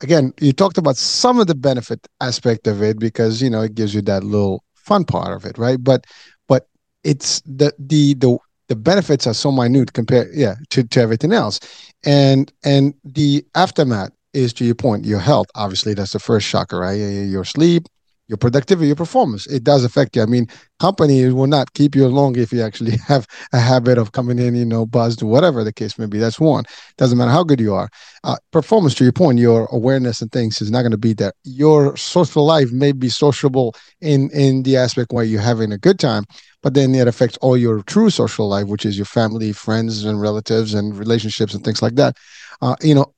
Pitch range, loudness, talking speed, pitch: 110-145 Hz, -16 LUFS, 215 wpm, 125 Hz